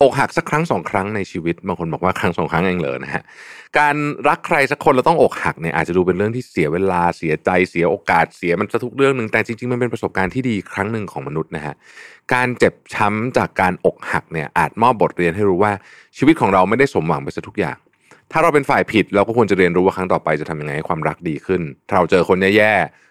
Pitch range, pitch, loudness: 90-125 Hz, 105 Hz, -18 LUFS